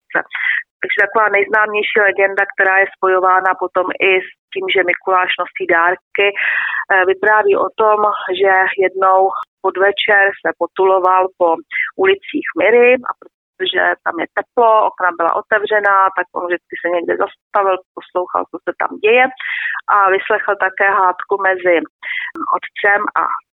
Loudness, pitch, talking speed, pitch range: -14 LUFS, 195 Hz, 130 wpm, 185-210 Hz